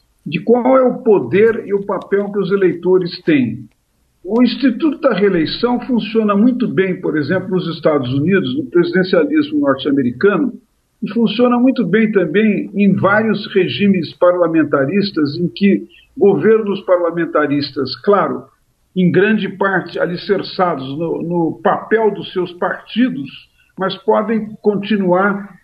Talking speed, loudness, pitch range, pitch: 125 wpm, -15 LUFS, 175-220 Hz, 195 Hz